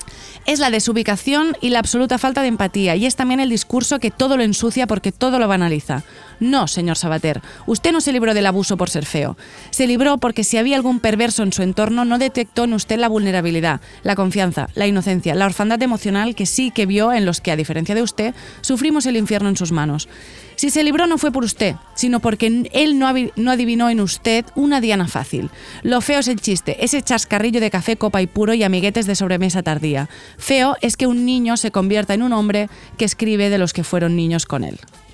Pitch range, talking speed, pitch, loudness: 190-250 Hz, 215 wpm, 220 Hz, -18 LUFS